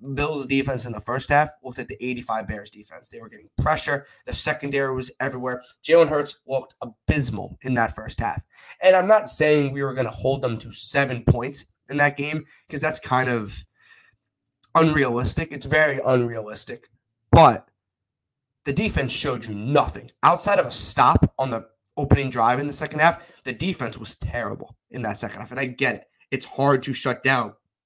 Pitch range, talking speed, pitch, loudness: 115-145 Hz, 185 wpm, 130 Hz, -22 LUFS